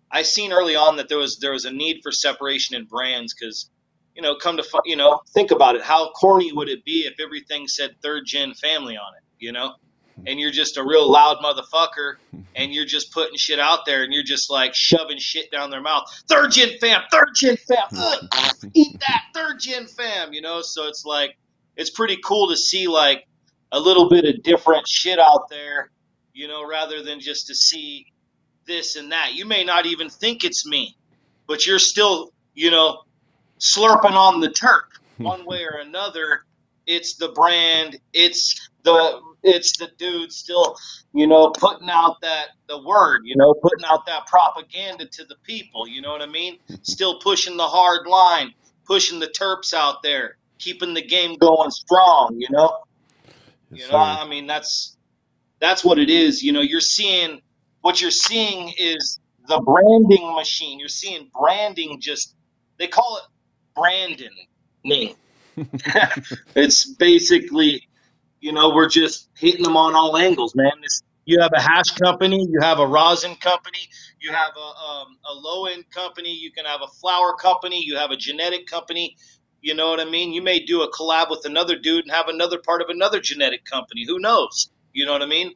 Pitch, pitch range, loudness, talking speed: 165 Hz, 150-190 Hz, -18 LUFS, 185 wpm